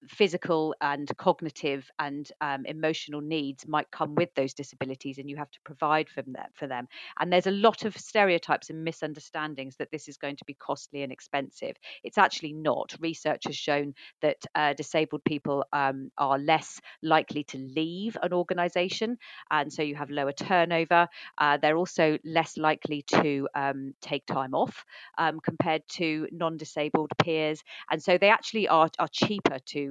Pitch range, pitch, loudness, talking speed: 145-165 Hz, 155 Hz, -28 LUFS, 175 wpm